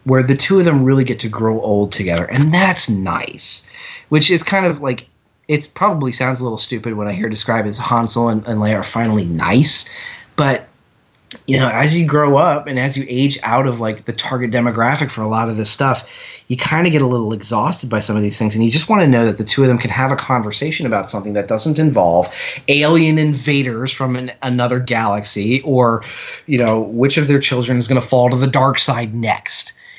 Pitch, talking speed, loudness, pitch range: 125 Hz, 230 wpm, -15 LUFS, 110-140 Hz